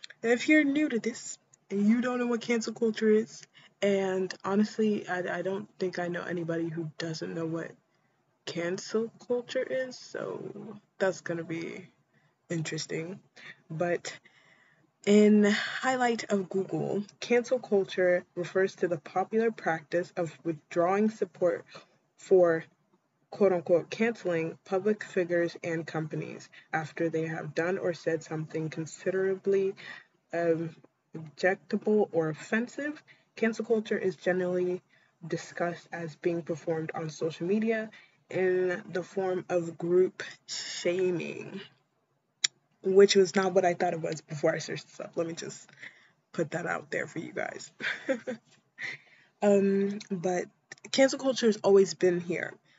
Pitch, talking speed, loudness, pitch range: 185 Hz, 135 wpm, -30 LUFS, 170-215 Hz